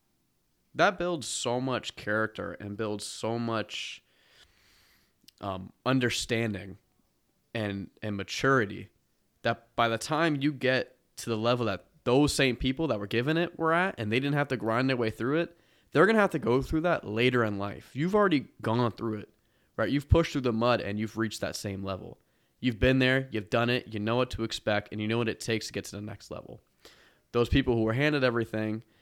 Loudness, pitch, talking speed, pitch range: -29 LUFS, 115 Hz, 205 wpm, 110-130 Hz